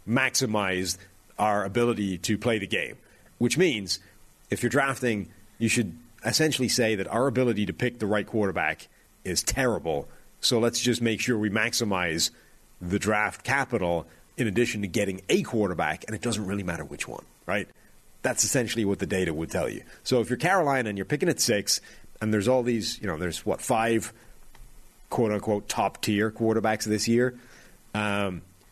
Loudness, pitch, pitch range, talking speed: -26 LUFS, 110 Hz, 100-120 Hz, 175 wpm